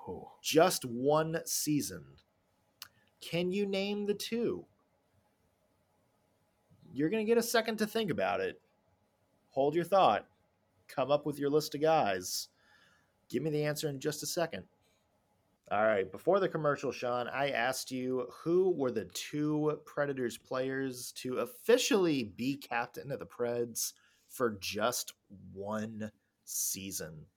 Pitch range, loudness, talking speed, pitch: 110-165 Hz, -33 LUFS, 135 wpm, 140 Hz